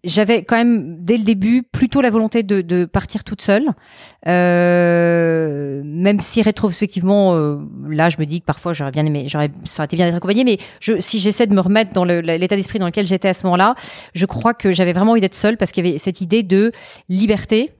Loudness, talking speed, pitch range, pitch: -16 LUFS, 230 wpm, 175-215 Hz, 190 Hz